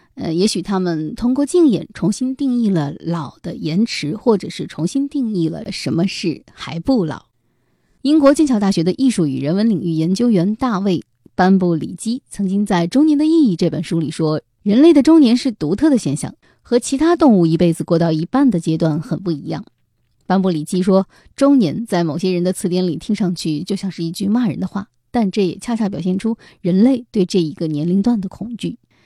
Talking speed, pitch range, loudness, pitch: 300 characters per minute, 170-240 Hz, -17 LUFS, 190 Hz